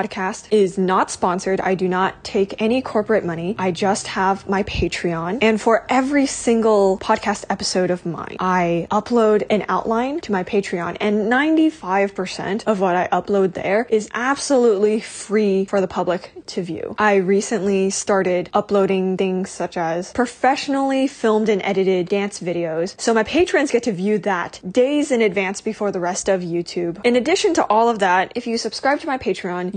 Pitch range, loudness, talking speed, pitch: 185-225 Hz, -19 LUFS, 175 wpm, 200 Hz